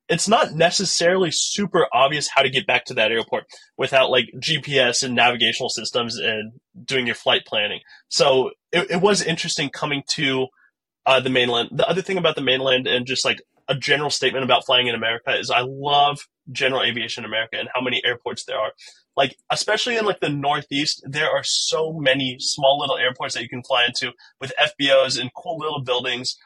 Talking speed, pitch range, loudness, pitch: 195 wpm, 125-165 Hz, -20 LUFS, 135 Hz